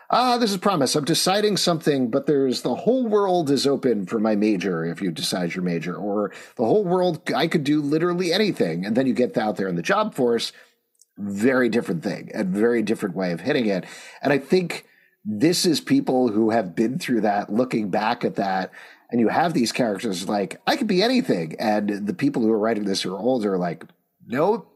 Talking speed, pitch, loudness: 220 wpm, 135 Hz, -22 LUFS